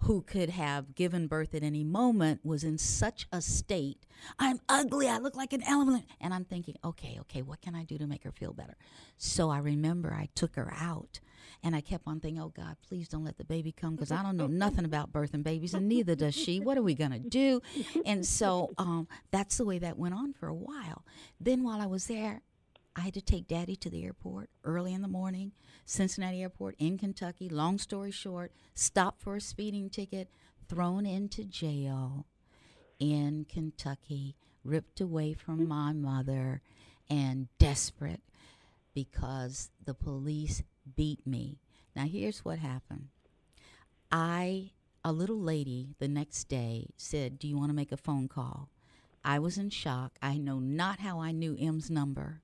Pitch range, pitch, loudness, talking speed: 140-190 Hz, 160 Hz, -34 LUFS, 185 wpm